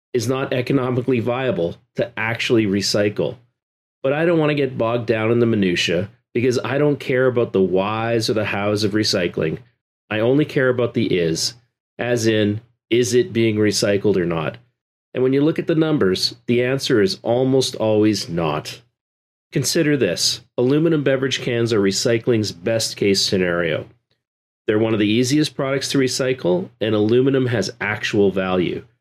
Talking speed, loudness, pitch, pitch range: 165 wpm, -19 LUFS, 120 Hz, 105-135 Hz